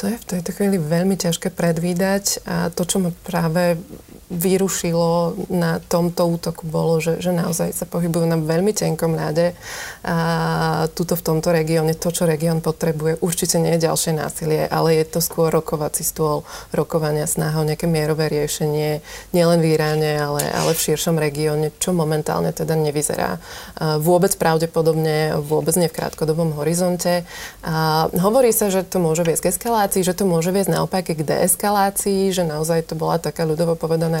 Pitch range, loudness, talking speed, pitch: 160-180 Hz, -19 LUFS, 170 wpm, 165 Hz